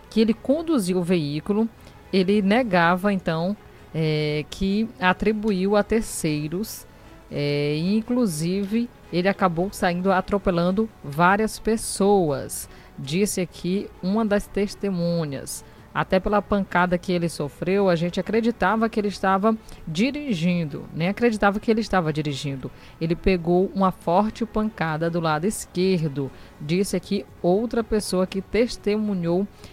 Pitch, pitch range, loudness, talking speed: 190 Hz, 170-210 Hz, -23 LUFS, 120 wpm